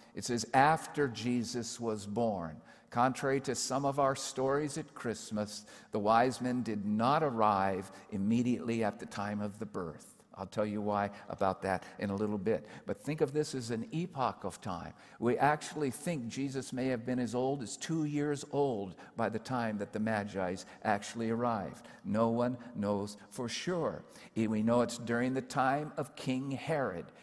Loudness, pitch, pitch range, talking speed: -34 LUFS, 120 Hz, 105-135 Hz, 180 wpm